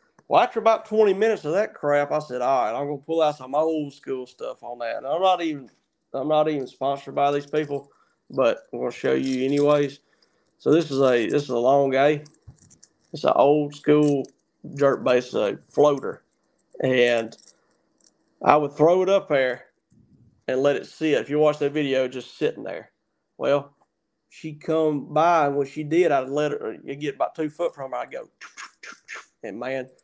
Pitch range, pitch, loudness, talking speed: 130-155 Hz, 145 Hz, -23 LUFS, 195 wpm